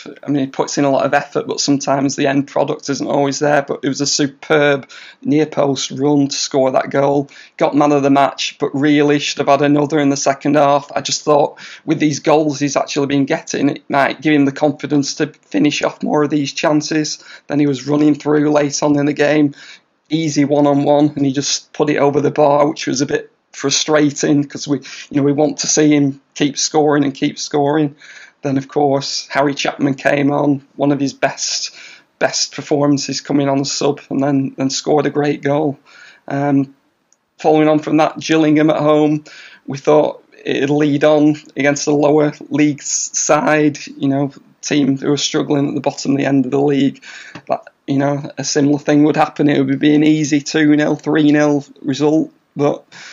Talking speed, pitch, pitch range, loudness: 205 wpm, 145 Hz, 140-150 Hz, -15 LUFS